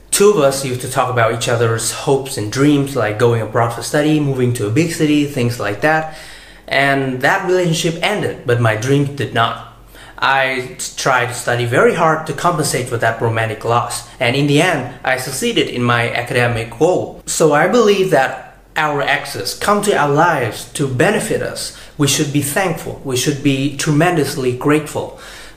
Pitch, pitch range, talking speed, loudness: 135 Hz, 120-155 Hz, 185 wpm, -16 LUFS